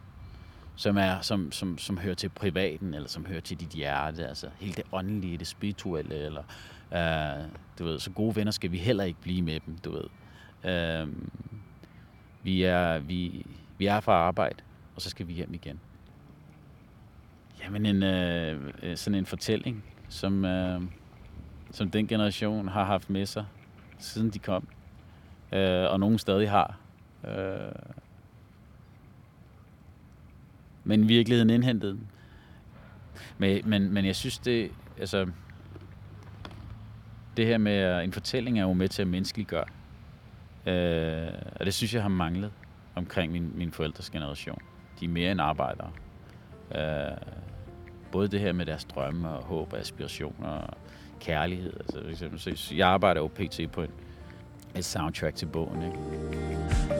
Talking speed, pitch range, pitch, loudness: 145 wpm, 85-100 Hz, 95 Hz, -30 LUFS